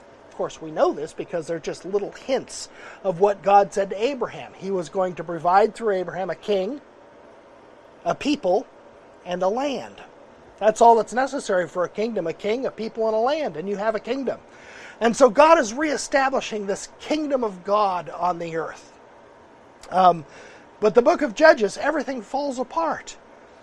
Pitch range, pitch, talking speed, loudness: 190-270 Hz, 215 Hz, 175 wpm, -22 LUFS